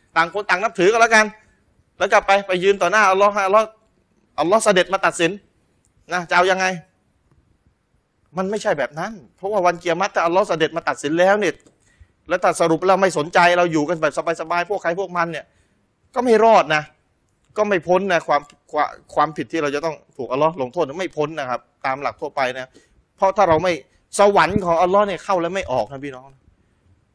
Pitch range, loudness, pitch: 155-195 Hz, -19 LUFS, 175 Hz